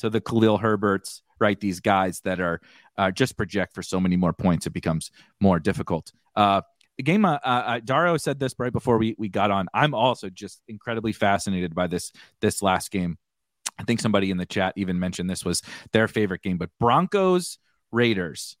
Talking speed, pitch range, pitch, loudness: 195 wpm, 95-115 Hz, 100 Hz, -24 LUFS